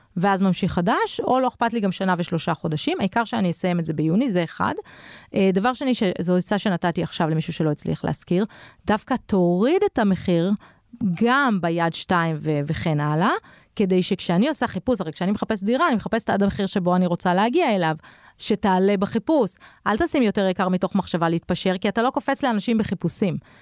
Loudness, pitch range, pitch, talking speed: -22 LUFS, 175-225 Hz, 195 Hz, 180 wpm